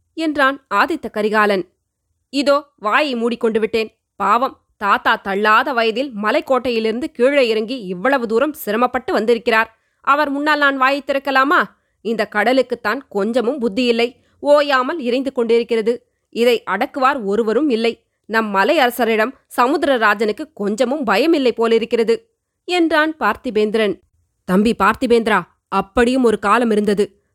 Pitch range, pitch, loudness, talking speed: 215-265 Hz, 235 Hz, -17 LUFS, 110 wpm